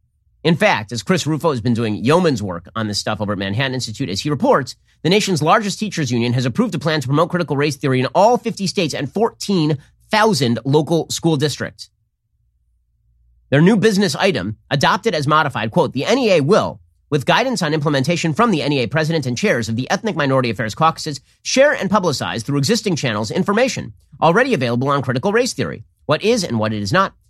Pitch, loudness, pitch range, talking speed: 145 Hz, -17 LUFS, 120-180 Hz, 200 wpm